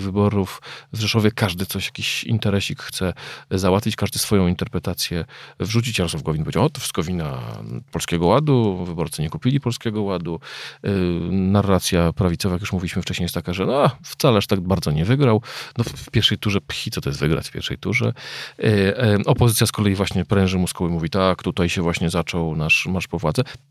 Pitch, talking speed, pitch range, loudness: 95 Hz, 185 wpm, 90-110 Hz, -21 LUFS